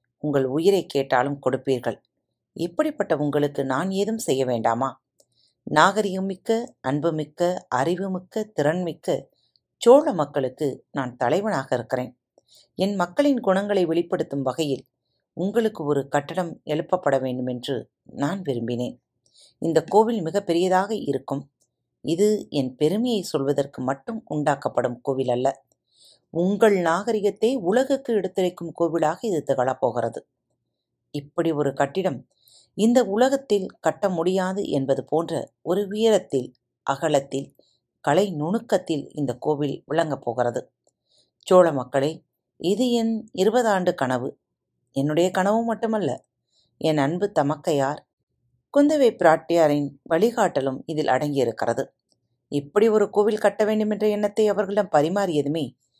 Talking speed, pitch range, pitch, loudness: 105 wpm, 135-200 Hz, 160 Hz, -23 LUFS